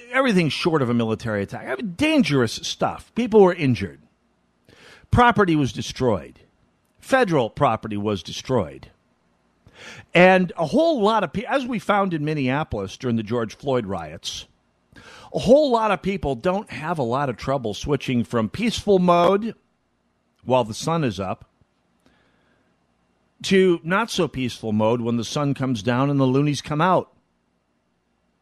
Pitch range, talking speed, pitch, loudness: 115-185 Hz, 150 wpm, 135 Hz, -21 LUFS